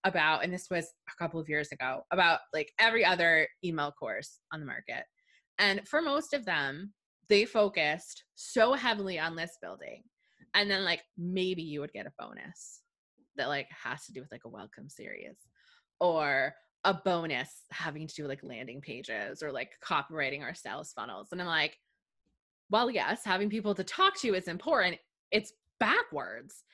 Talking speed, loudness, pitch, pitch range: 175 wpm, -31 LUFS, 185 Hz, 160-220 Hz